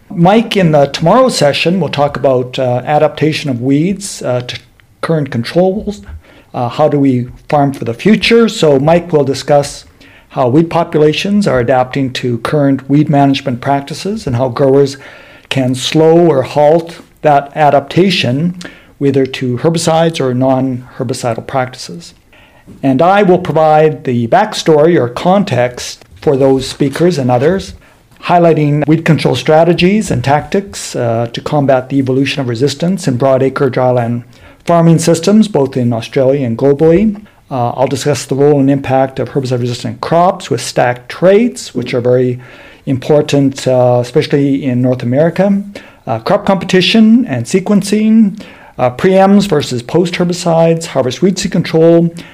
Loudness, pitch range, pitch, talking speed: -11 LUFS, 130-170 Hz, 145 Hz, 145 wpm